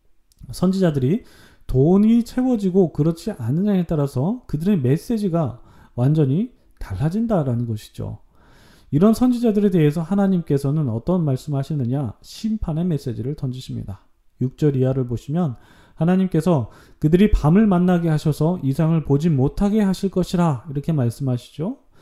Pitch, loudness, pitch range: 155 Hz, -20 LUFS, 130-185 Hz